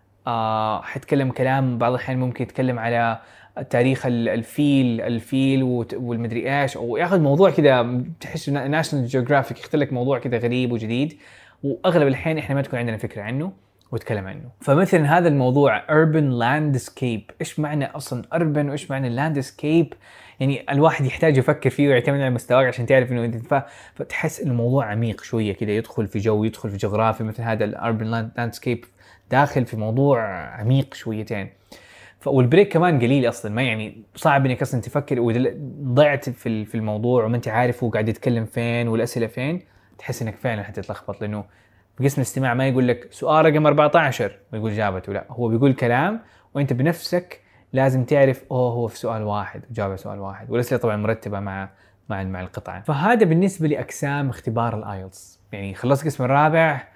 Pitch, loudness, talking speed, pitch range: 125 Hz, -21 LUFS, 155 wpm, 110-140 Hz